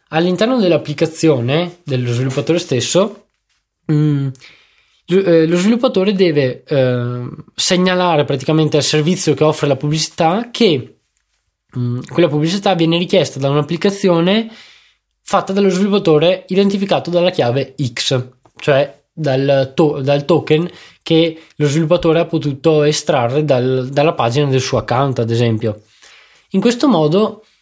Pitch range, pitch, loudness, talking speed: 140-180 Hz, 155 Hz, -15 LUFS, 115 wpm